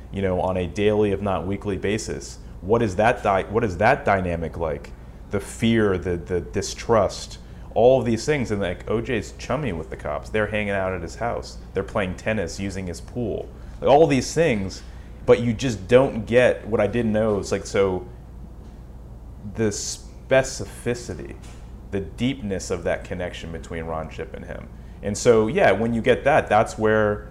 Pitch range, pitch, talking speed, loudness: 90-110 Hz, 100 Hz, 185 wpm, -23 LUFS